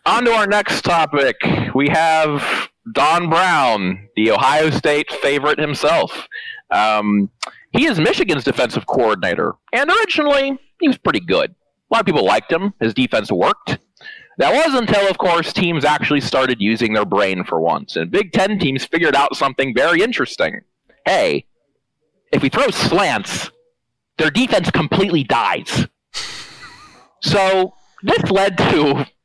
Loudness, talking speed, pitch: -16 LUFS, 145 wpm, 170 Hz